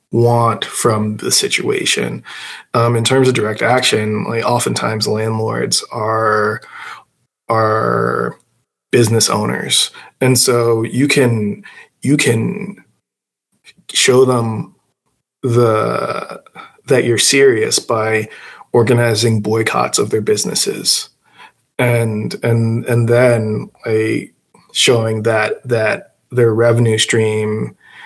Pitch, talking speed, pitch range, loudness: 115 Hz, 100 wpm, 110-120 Hz, -14 LUFS